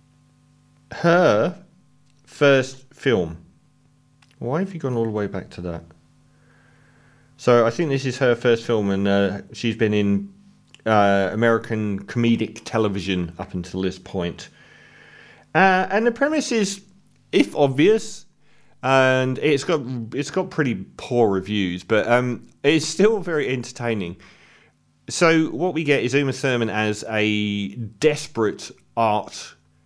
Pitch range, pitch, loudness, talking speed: 105-145 Hz, 130 Hz, -21 LUFS, 135 wpm